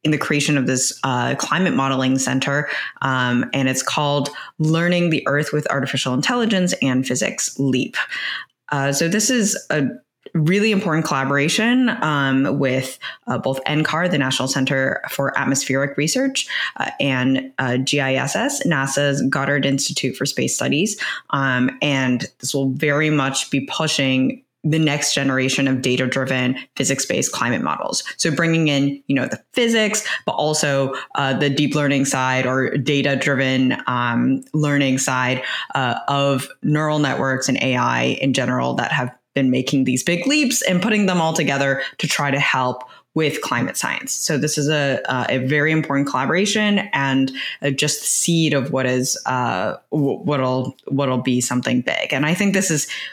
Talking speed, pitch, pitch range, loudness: 160 wpm, 140 Hz, 130-155 Hz, -19 LUFS